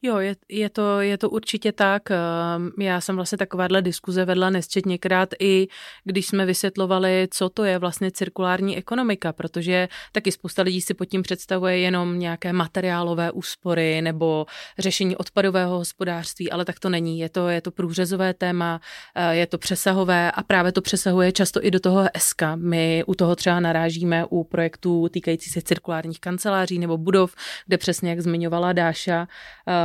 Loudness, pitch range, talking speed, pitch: -22 LUFS, 170-190 Hz, 165 wpm, 180 Hz